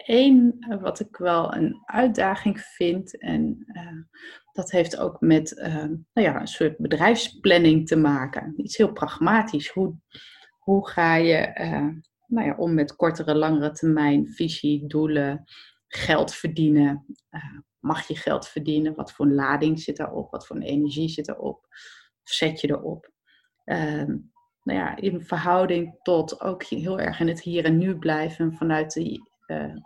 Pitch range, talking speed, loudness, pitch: 155-195 Hz, 155 wpm, -23 LUFS, 165 Hz